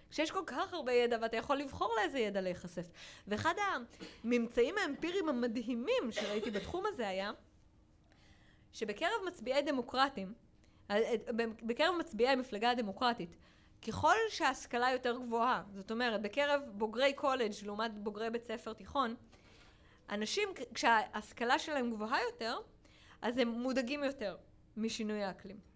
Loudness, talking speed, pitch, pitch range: -36 LUFS, 120 wpm, 235 Hz, 205-275 Hz